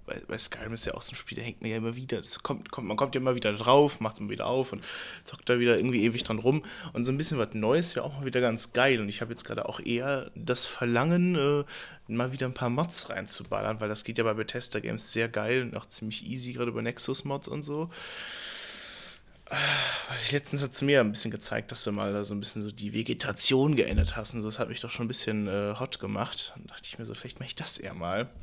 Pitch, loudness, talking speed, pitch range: 120 Hz, -29 LUFS, 270 wpm, 110-130 Hz